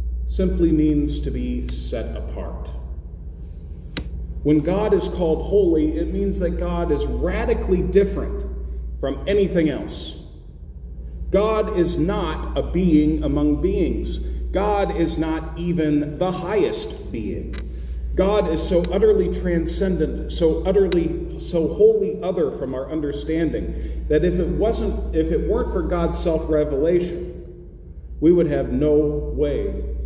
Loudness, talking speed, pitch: -22 LUFS, 125 wpm, 160 Hz